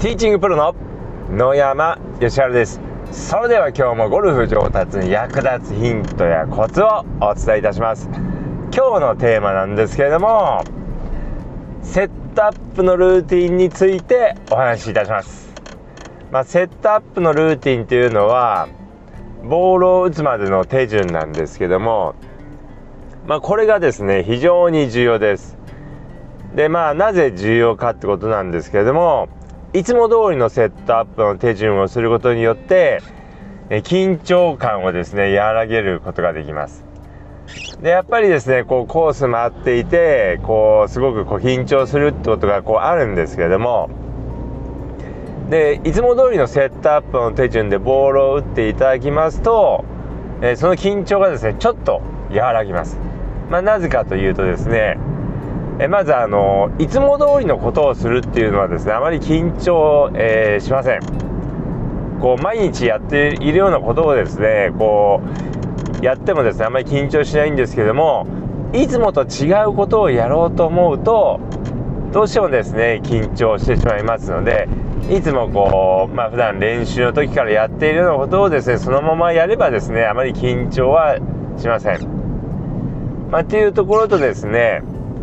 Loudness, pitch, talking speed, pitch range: -16 LUFS, 135 Hz, 325 characters per minute, 110-175 Hz